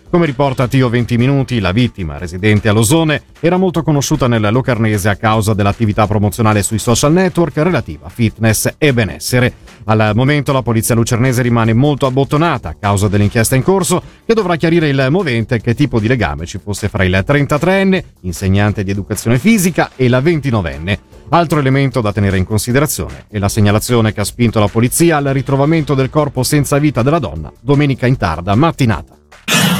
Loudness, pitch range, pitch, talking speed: -13 LUFS, 105-145 Hz, 120 Hz, 175 wpm